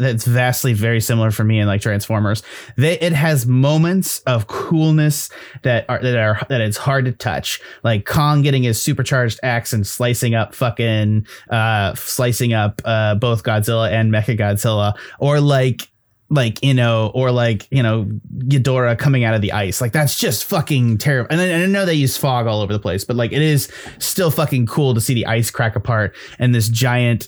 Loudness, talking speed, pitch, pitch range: -17 LUFS, 200 wpm, 120 Hz, 110-135 Hz